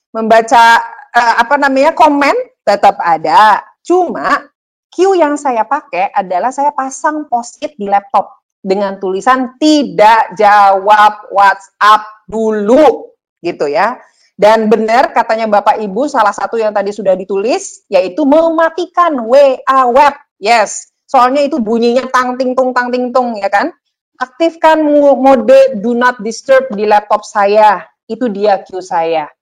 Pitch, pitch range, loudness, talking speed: 250 Hz, 210-290 Hz, -10 LUFS, 135 wpm